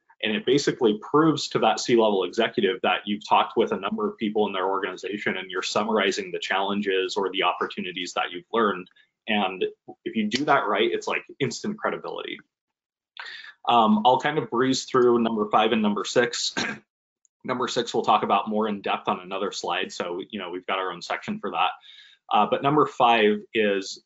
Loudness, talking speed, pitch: -24 LUFS, 195 wpm, 120 Hz